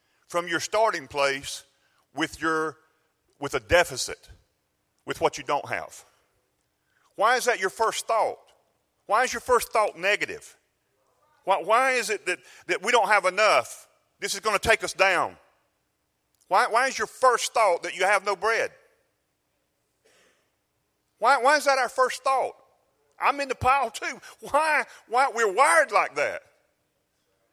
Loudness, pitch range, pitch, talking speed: -24 LUFS, 185-295 Hz, 245 Hz, 155 wpm